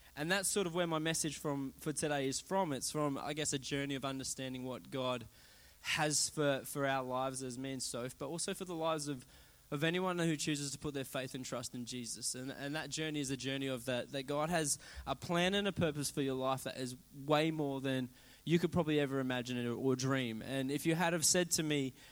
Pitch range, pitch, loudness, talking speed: 130-155 Hz, 140 Hz, -37 LUFS, 240 wpm